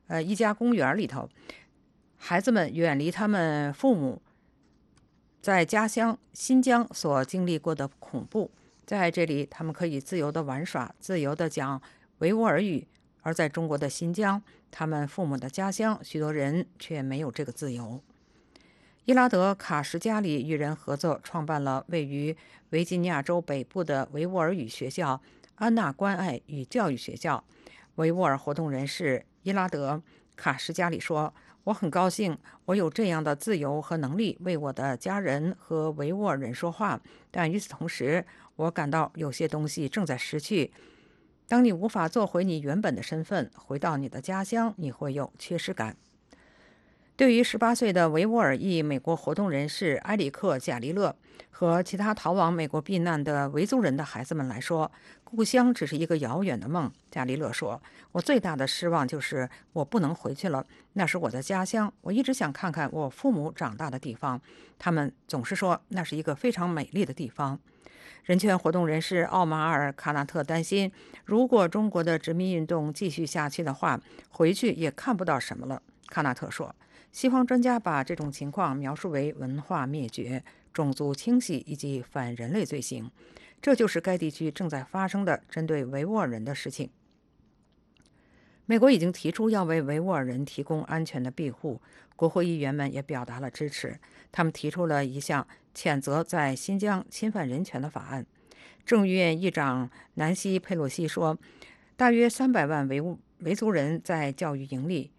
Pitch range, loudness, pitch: 145-190 Hz, -28 LUFS, 165 Hz